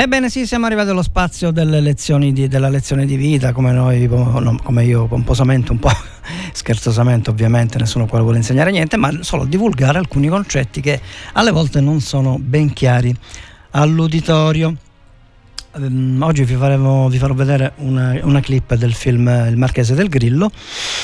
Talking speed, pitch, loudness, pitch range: 155 wpm, 135 Hz, -15 LUFS, 120-150 Hz